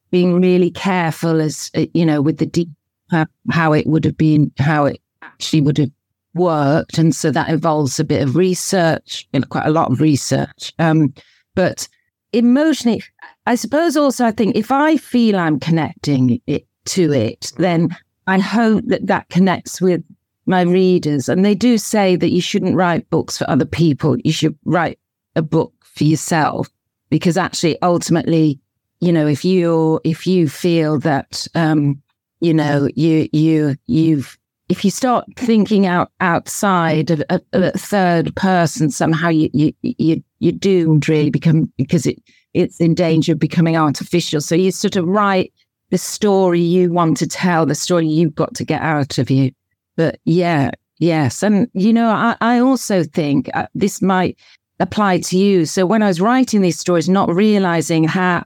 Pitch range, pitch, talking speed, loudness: 155-185 Hz, 165 Hz, 175 wpm, -16 LUFS